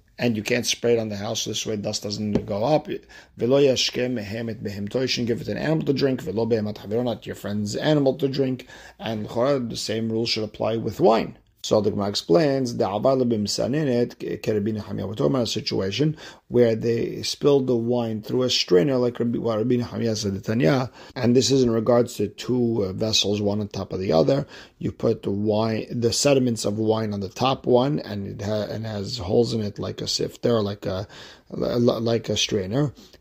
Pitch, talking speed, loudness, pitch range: 115 Hz, 185 wpm, -23 LUFS, 105-125 Hz